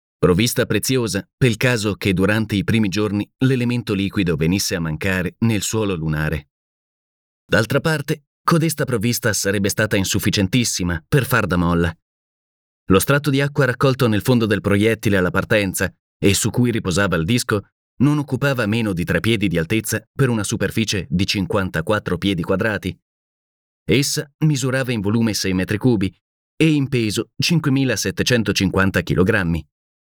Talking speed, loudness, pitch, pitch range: 145 wpm, -19 LUFS, 105 Hz, 95-125 Hz